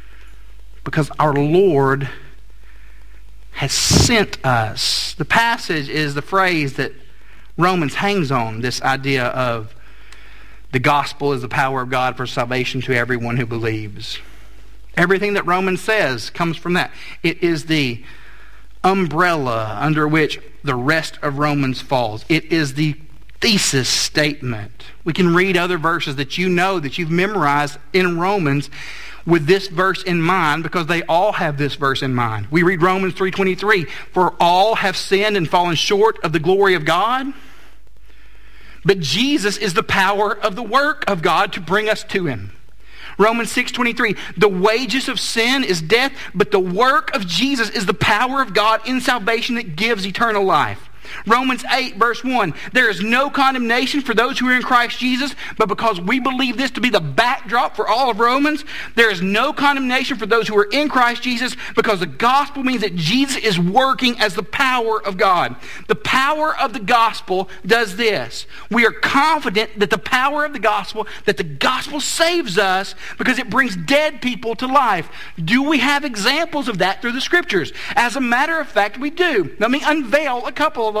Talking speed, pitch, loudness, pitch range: 175 wpm, 195 Hz, -17 LUFS, 150-245 Hz